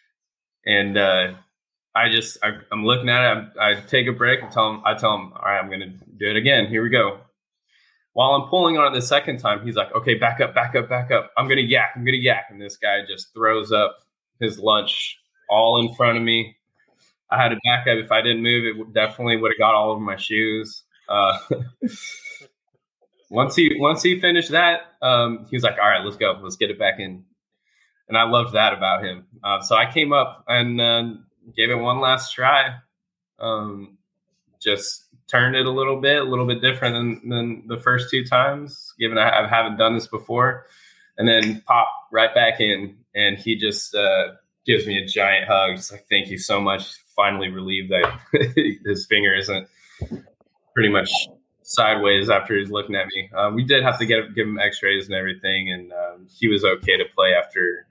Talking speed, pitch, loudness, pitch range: 205 wpm, 115 Hz, -19 LUFS, 105-125 Hz